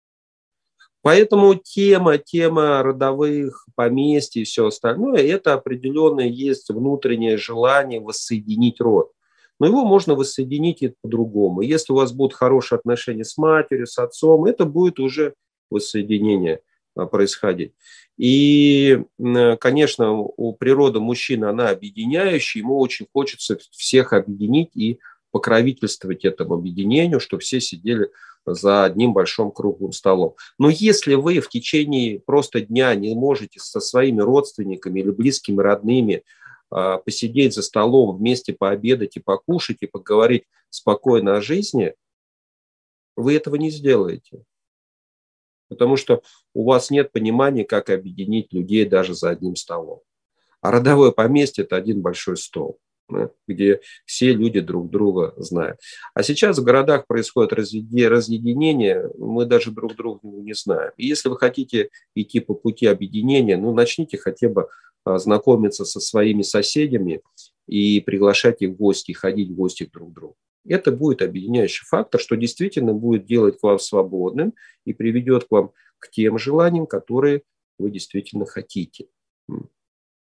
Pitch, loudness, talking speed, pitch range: 125 Hz, -19 LUFS, 130 wpm, 105-145 Hz